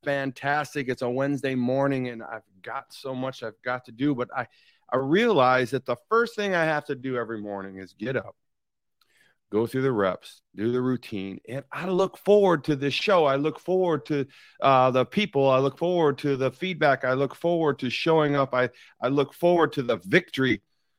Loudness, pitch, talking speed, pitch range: -25 LUFS, 135 Hz, 205 wpm, 125-150 Hz